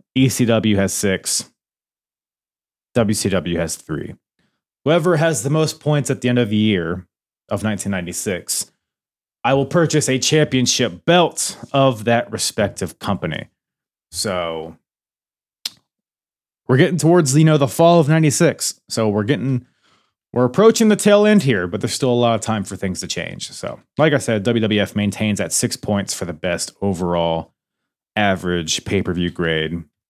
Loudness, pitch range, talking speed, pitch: -18 LUFS, 95-145 Hz, 150 wpm, 115 Hz